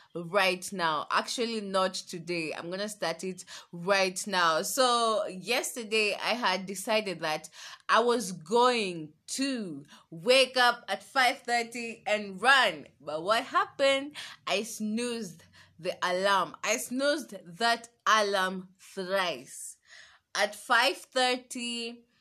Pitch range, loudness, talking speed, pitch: 185-240 Hz, -28 LUFS, 115 wpm, 210 Hz